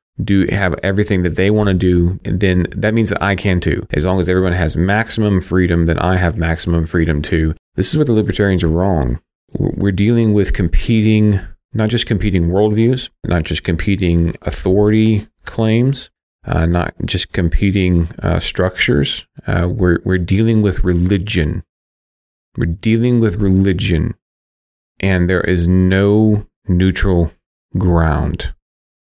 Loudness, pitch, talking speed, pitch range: -15 LUFS, 95 Hz, 145 wpm, 85-105 Hz